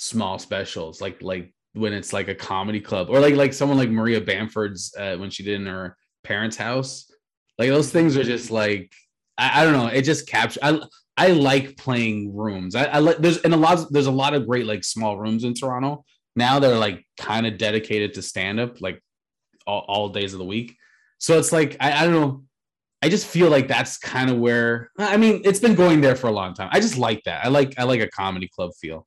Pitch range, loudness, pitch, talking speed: 105-145 Hz, -21 LUFS, 120 Hz, 235 wpm